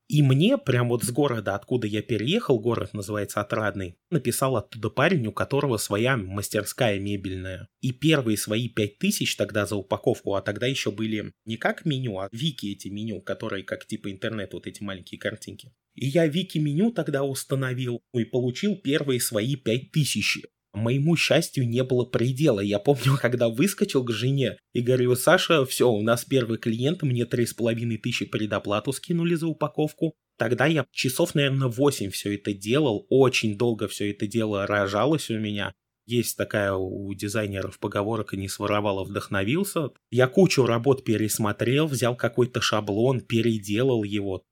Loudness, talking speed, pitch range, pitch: -25 LUFS, 160 wpm, 105-135 Hz, 120 Hz